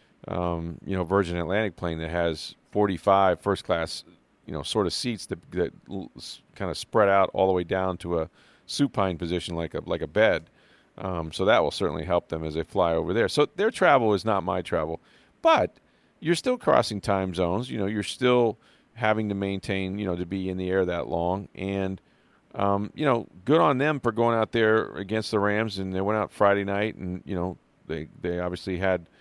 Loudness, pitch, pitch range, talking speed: -26 LUFS, 95 Hz, 90-105 Hz, 210 wpm